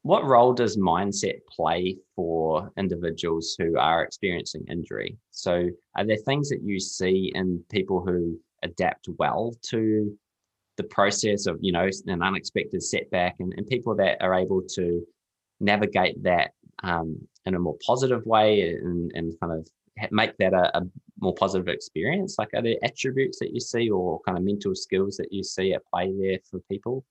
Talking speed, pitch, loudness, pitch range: 175 wpm, 95 Hz, -26 LUFS, 90-105 Hz